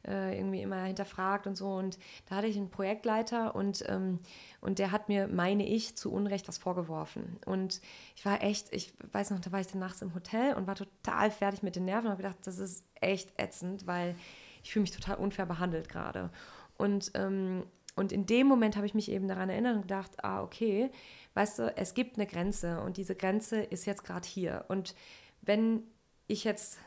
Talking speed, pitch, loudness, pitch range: 205 wpm, 195 Hz, -34 LUFS, 185-205 Hz